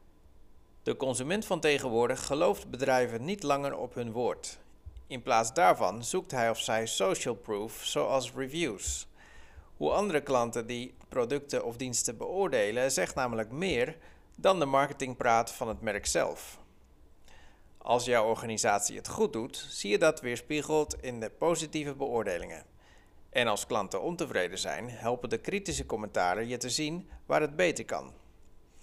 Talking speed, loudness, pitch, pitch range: 145 wpm, -31 LUFS, 120 Hz, 90-145 Hz